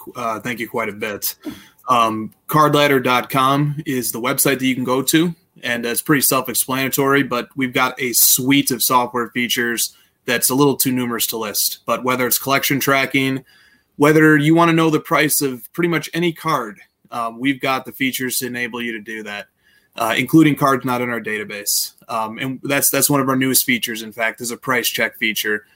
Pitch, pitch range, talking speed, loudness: 130 Hz, 120-140 Hz, 200 wpm, -17 LUFS